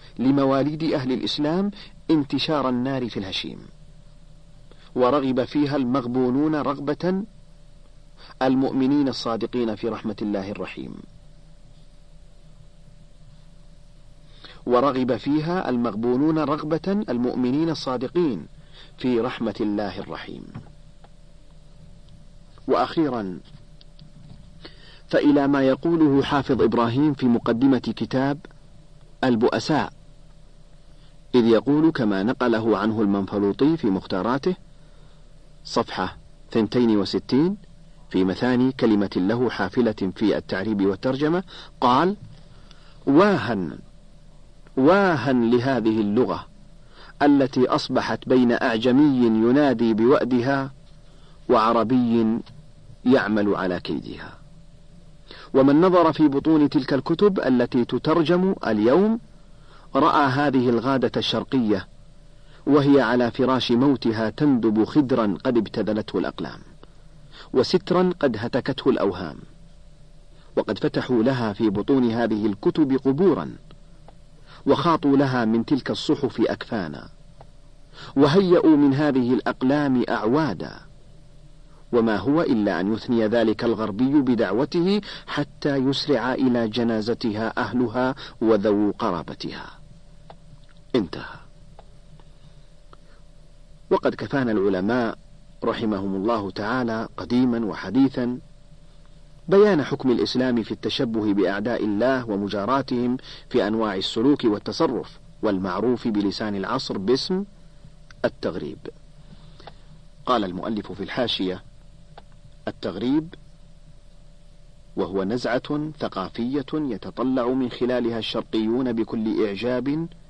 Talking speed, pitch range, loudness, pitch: 85 wpm, 120-150 Hz, -22 LUFS, 140 Hz